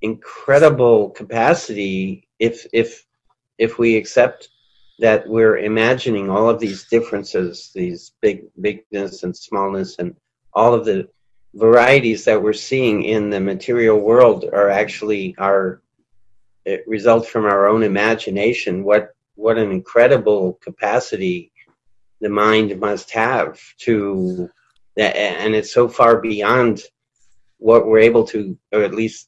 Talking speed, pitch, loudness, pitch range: 125 wpm, 105 Hz, -17 LUFS, 100-115 Hz